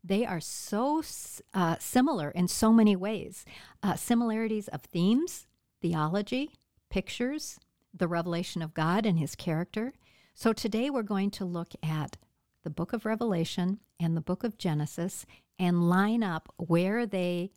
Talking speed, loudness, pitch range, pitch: 145 wpm, -30 LUFS, 170-225 Hz, 190 Hz